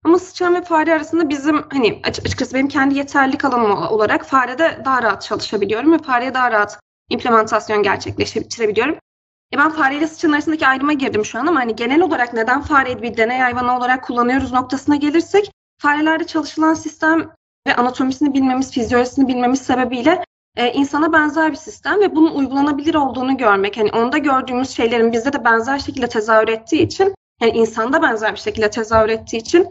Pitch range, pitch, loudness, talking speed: 240-315 Hz, 270 Hz, -16 LUFS, 170 wpm